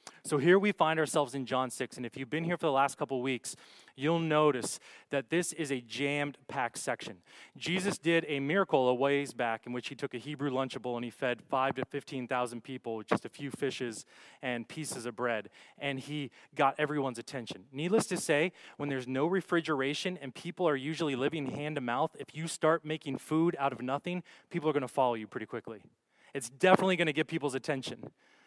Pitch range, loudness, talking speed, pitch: 130-160 Hz, -33 LUFS, 215 wpm, 140 Hz